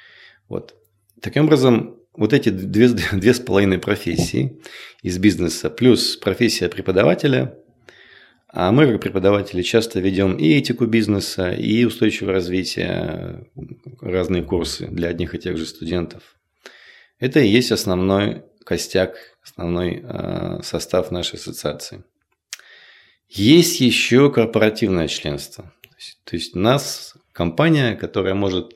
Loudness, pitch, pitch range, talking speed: -19 LUFS, 100 Hz, 90-115 Hz, 120 wpm